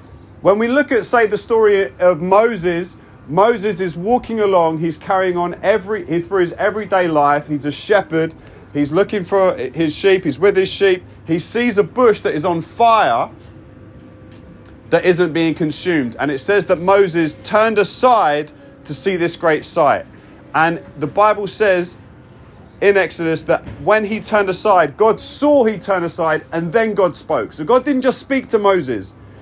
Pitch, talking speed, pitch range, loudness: 185 Hz, 175 wpm, 160-210 Hz, -16 LUFS